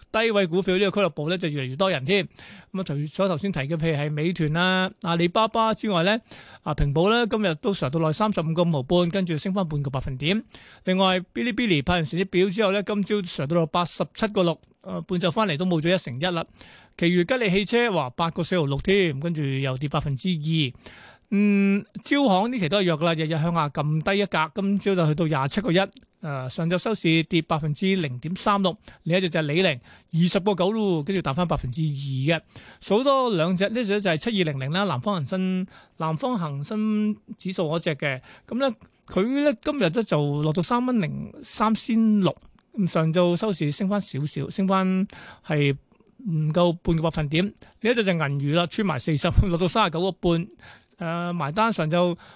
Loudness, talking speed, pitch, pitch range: -24 LUFS, 310 characters per minute, 180 Hz, 160-200 Hz